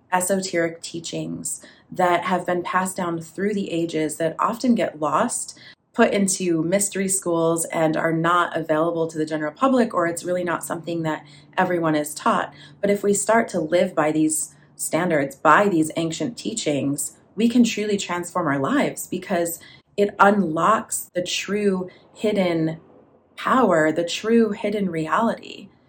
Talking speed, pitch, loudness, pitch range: 150 wpm, 175 Hz, -22 LUFS, 160-195 Hz